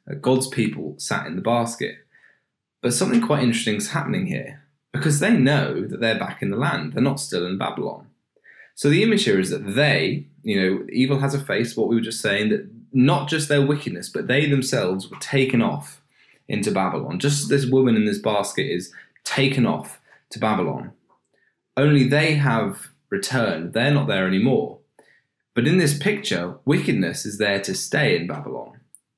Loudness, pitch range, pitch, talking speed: -21 LUFS, 115-150 Hz, 140 Hz, 180 wpm